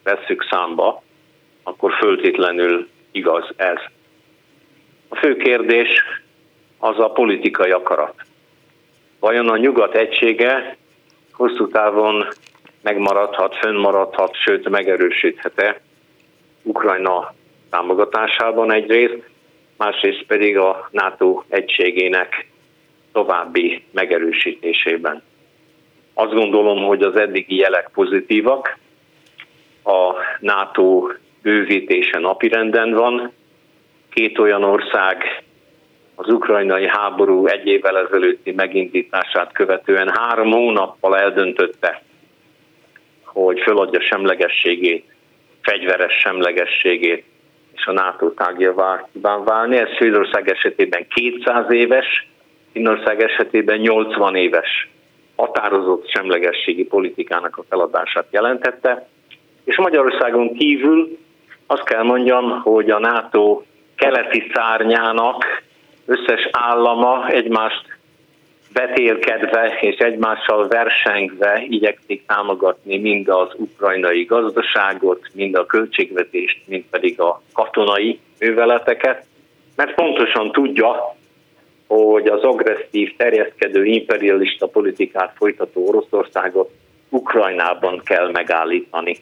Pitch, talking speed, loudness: 125 Hz, 90 wpm, -16 LUFS